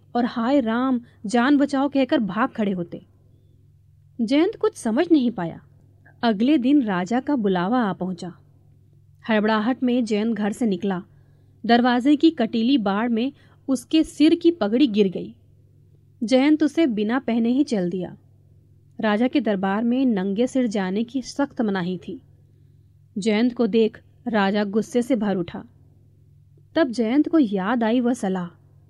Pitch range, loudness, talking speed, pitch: 165-255 Hz, -22 LUFS, 145 wpm, 220 Hz